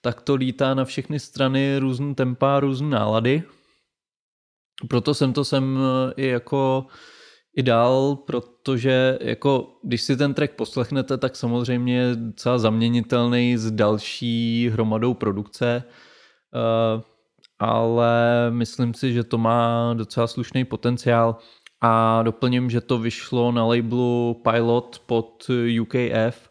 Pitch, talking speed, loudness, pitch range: 120 Hz, 120 wpm, -22 LUFS, 115-130 Hz